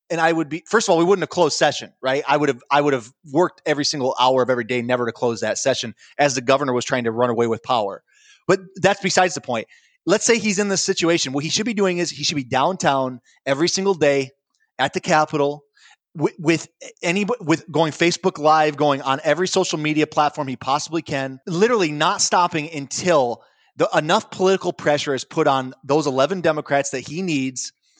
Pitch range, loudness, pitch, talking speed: 135-180 Hz, -20 LUFS, 150 Hz, 215 wpm